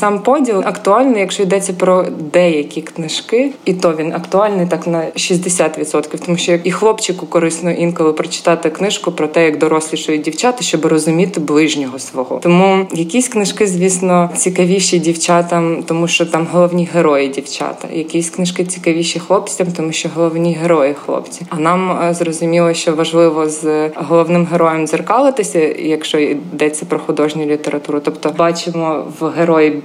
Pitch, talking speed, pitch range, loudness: 170 Hz, 145 wpm, 160-180 Hz, -14 LUFS